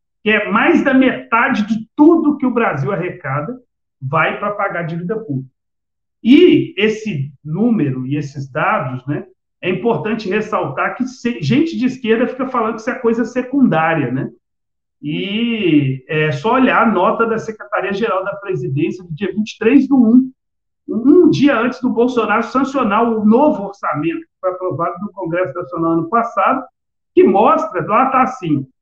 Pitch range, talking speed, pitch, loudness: 170-250 Hz, 160 wpm, 215 Hz, -16 LUFS